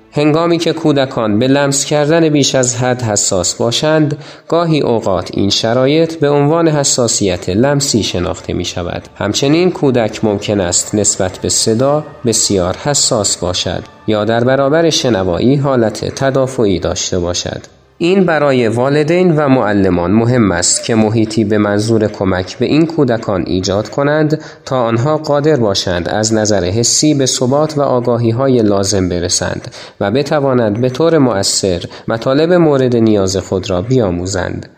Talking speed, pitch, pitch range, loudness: 140 wpm, 120 Hz, 100-145 Hz, -13 LUFS